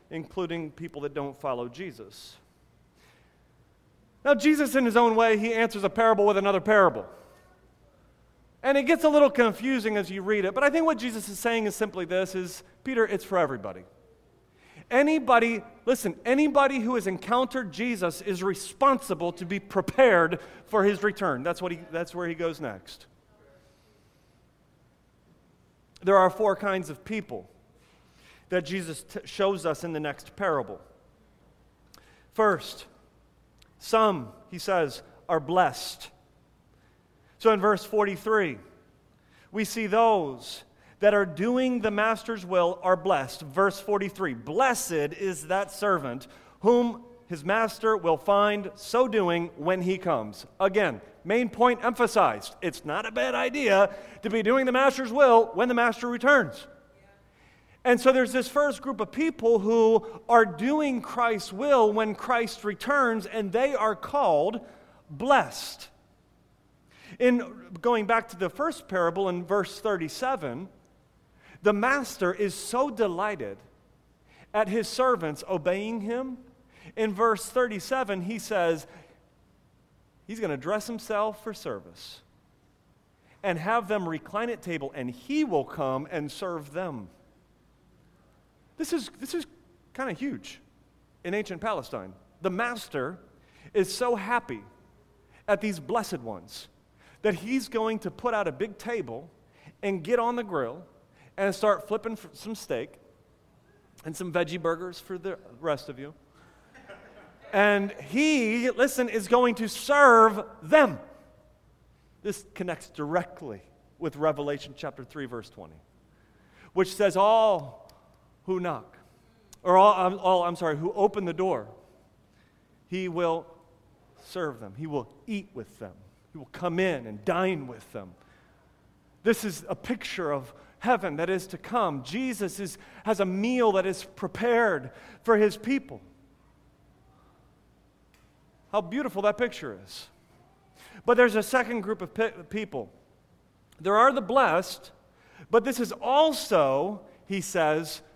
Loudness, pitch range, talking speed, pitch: -26 LUFS, 180-235 Hz, 140 wpm, 205 Hz